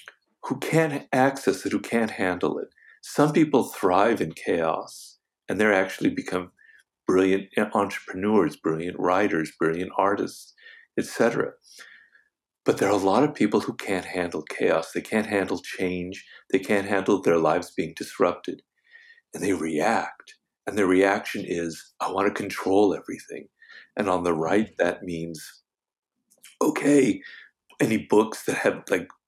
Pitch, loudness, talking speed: 100 Hz, -25 LUFS, 145 wpm